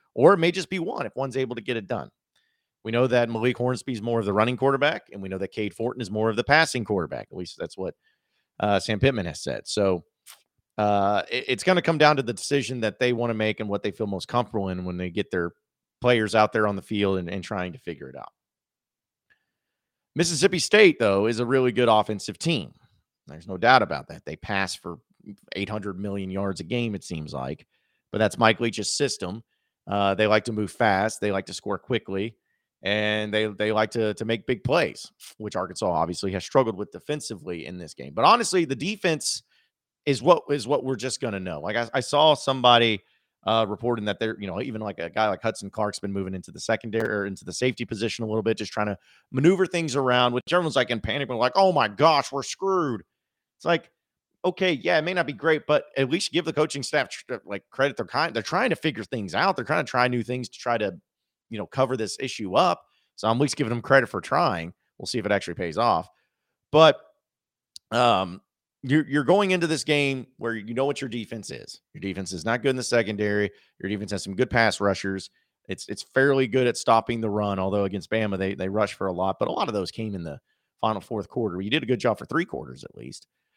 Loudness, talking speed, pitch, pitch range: -25 LUFS, 235 wpm, 115 Hz, 100-135 Hz